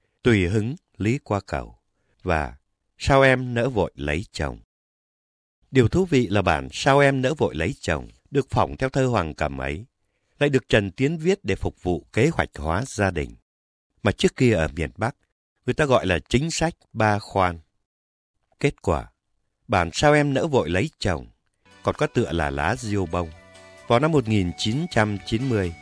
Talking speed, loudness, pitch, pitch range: 175 wpm, -23 LUFS, 100 Hz, 85-125 Hz